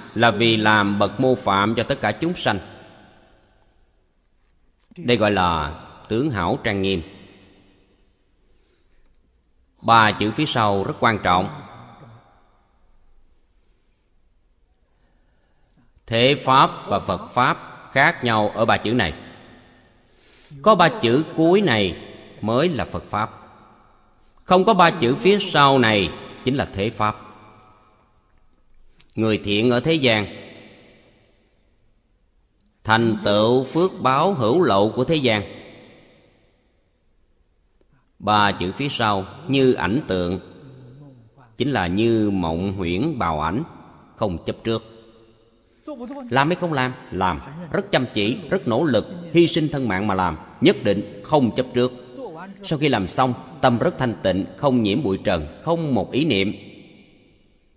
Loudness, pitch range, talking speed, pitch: -20 LUFS, 95-130 Hz, 130 wpm, 110 Hz